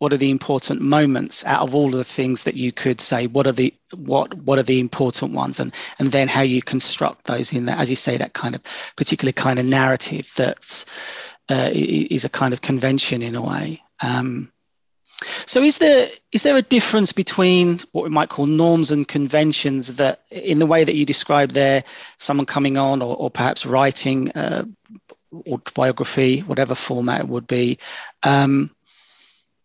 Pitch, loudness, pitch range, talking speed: 135 Hz, -19 LUFS, 130-150 Hz, 185 wpm